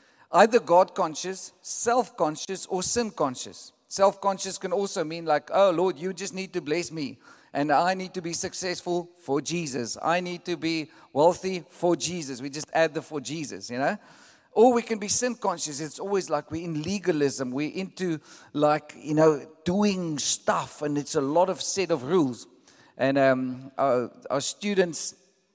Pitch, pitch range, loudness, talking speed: 175 Hz, 150-190 Hz, -26 LUFS, 180 wpm